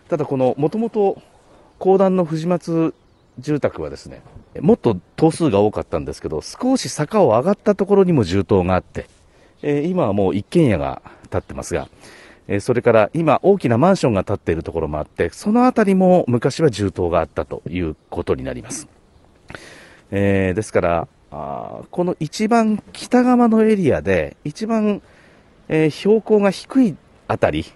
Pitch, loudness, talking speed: 160 Hz, -18 LUFS, 320 characters per minute